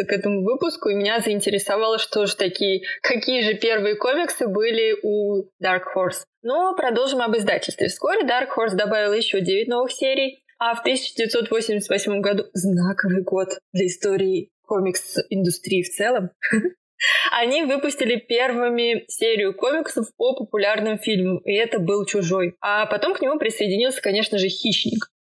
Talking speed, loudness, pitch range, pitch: 145 wpm, -21 LUFS, 195-250 Hz, 215 Hz